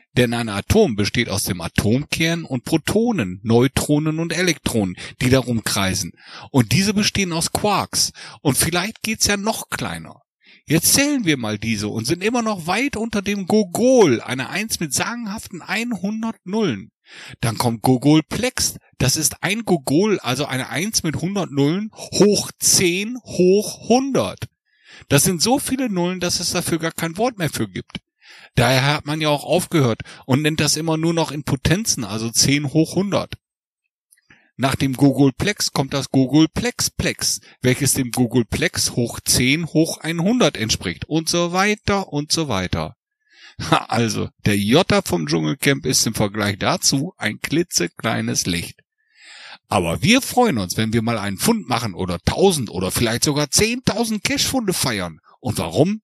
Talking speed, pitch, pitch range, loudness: 155 wpm, 155 Hz, 120-195 Hz, -19 LUFS